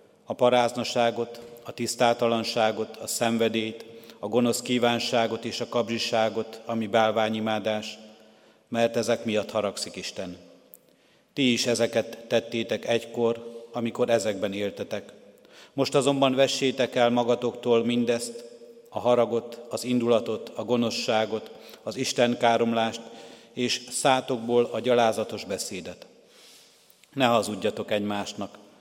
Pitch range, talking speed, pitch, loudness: 110-120 Hz, 105 wpm, 115 Hz, -26 LUFS